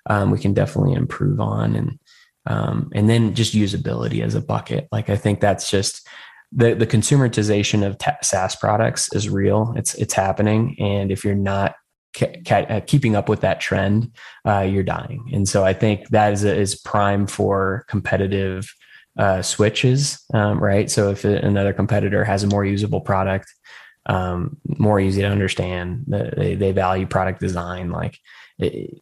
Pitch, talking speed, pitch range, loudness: 105 Hz, 170 wpm, 100-115 Hz, -20 LUFS